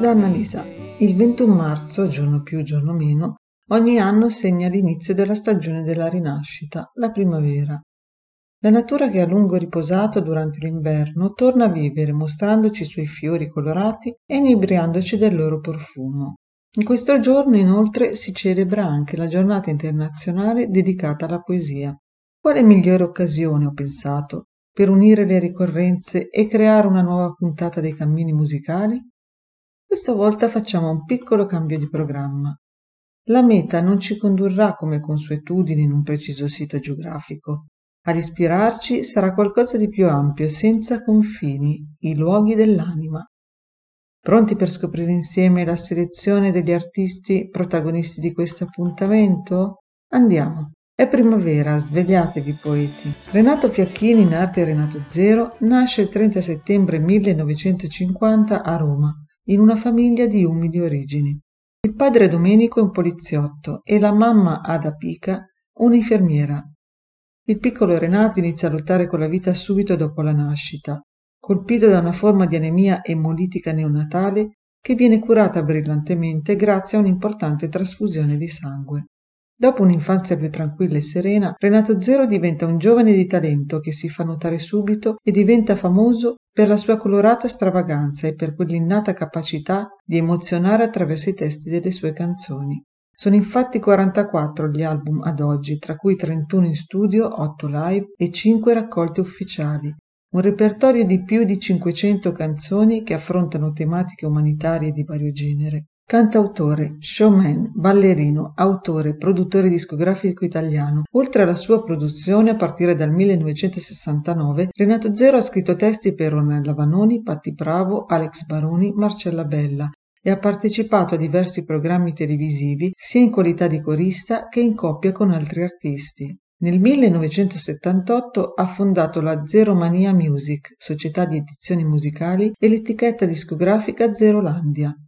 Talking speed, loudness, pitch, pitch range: 140 wpm, -18 LUFS, 180 Hz, 155-210 Hz